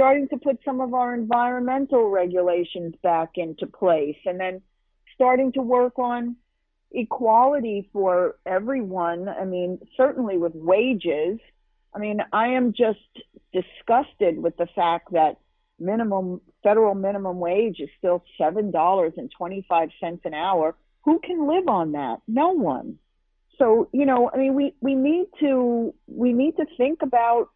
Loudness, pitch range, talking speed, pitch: -23 LUFS, 180-255 Hz, 150 wpm, 220 Hz